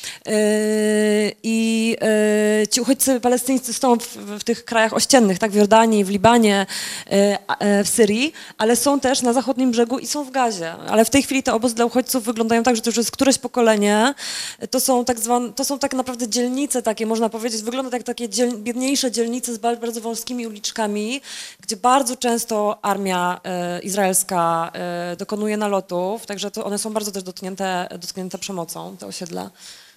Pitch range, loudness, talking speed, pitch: 205-245 Hz, -20 LUFS, 170 wpm, 225 Hz